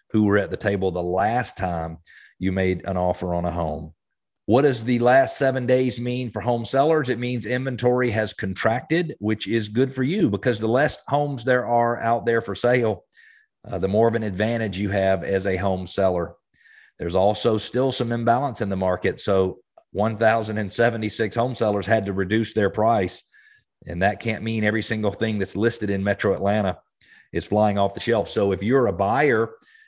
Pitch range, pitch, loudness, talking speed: 95-120 Hz, 110 Hz, -22 LUFS, 195 wpm